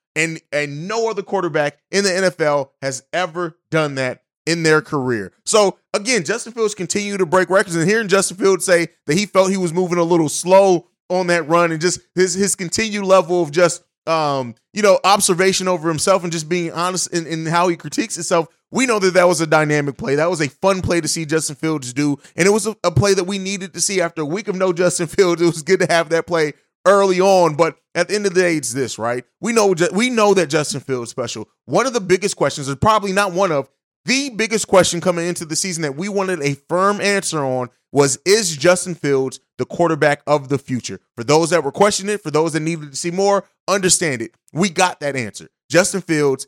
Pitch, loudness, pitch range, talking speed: 175 Hz, -17 LUFS, 155-195 Hz, 235 wpm